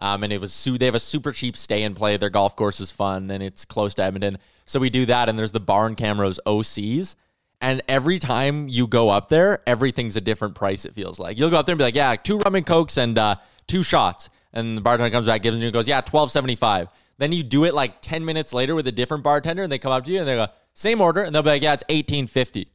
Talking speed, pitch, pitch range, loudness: 275 wpm, 125 Hz, 105-145 Hz, -21 LUFS